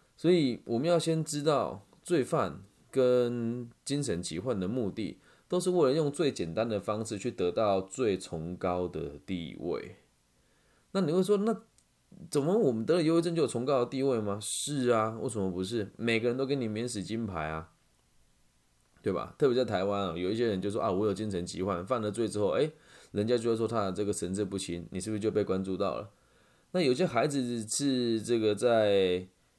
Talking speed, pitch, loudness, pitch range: 280 characters per minute, 110 Hz, -31 LUFS, 95-130 Hz